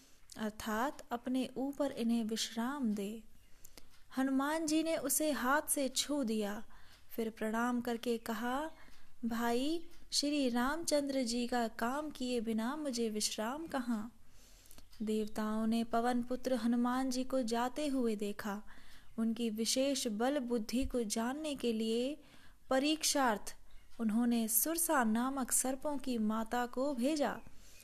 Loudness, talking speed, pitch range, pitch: -36 LUFS, 120 wpm, 230-275 Hz, 245 Hz